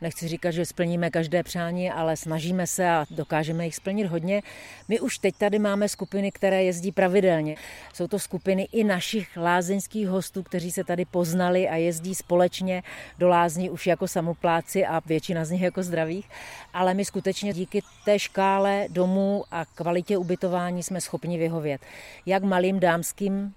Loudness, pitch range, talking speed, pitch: -26 LUFS, 170-195 Hz, 165 wpm, 180 Hz